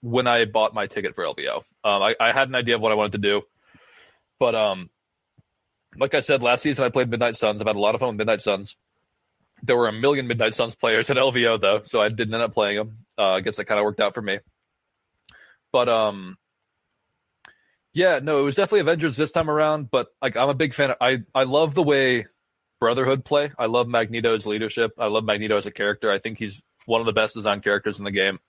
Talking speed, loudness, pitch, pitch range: 240 wpm, -22 LUFS, 115 Hz, 110-135 Hz